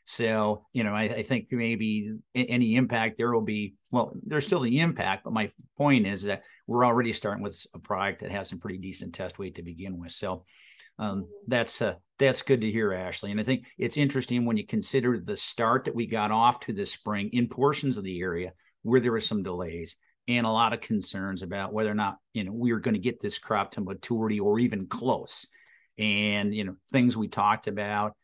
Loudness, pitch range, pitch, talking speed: -28 LUFS, 100-120 Hz, 110 Hz, 220 wpm